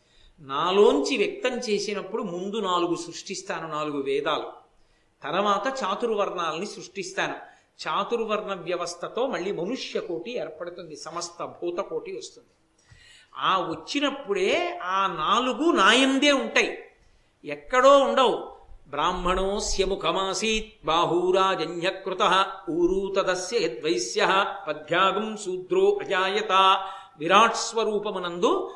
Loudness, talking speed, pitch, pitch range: -24 LUFS, 75 wpm, 195 Hz, 180-270 Hz